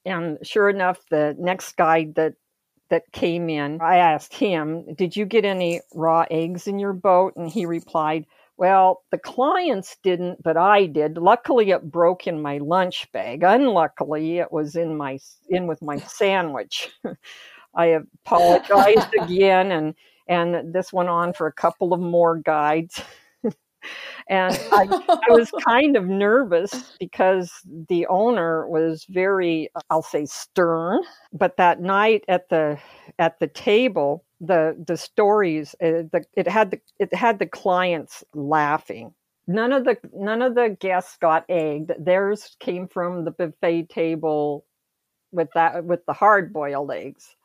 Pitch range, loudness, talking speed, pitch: 160-195 Hz, -21 LUFS, 150 wpm, 175 Hz